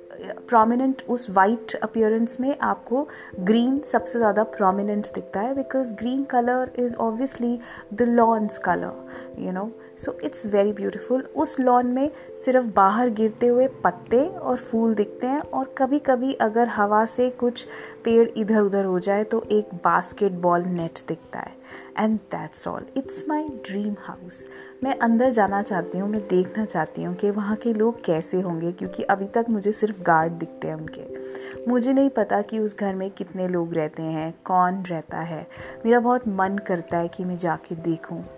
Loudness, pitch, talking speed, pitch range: -23 LUFS, 215 Hz, 170 wpm, 185-245 Hz